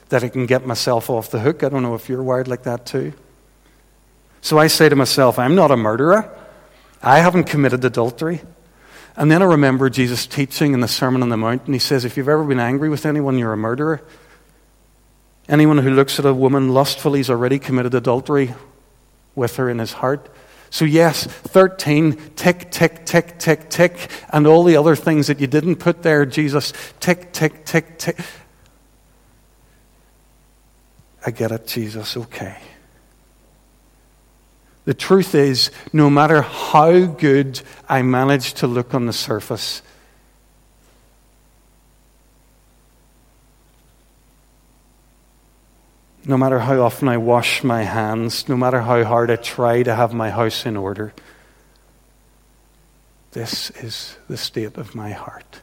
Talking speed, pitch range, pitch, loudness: 150 wpm, 120-155 Hz, 135 Hz, -17 LUFS